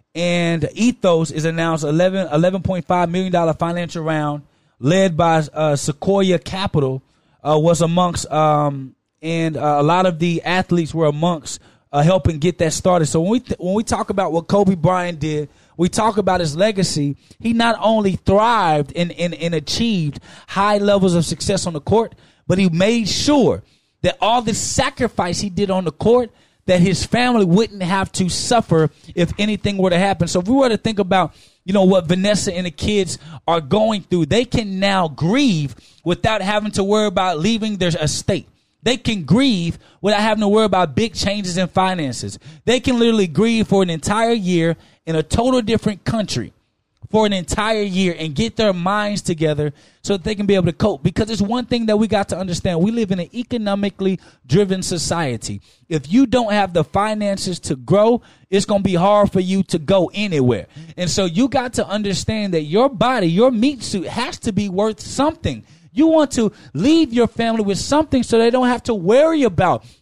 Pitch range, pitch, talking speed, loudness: 165-215 Hz, 190 Hz, 195 wpm, -18 LUFS